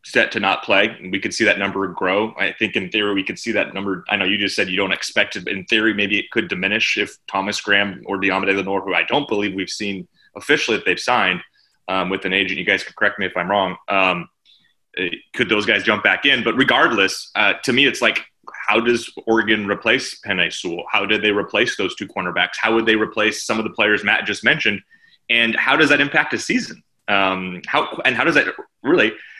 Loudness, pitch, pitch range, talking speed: -18 LUFS, 100 Hz, 95-110 Hz, 235 wpm